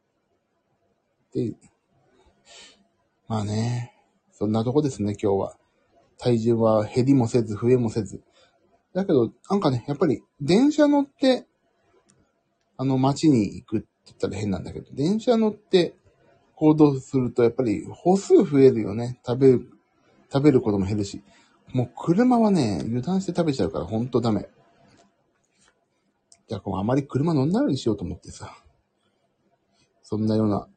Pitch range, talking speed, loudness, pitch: 110-155 Hz, 280 characters per minute, -23 LUFS, 125 Hz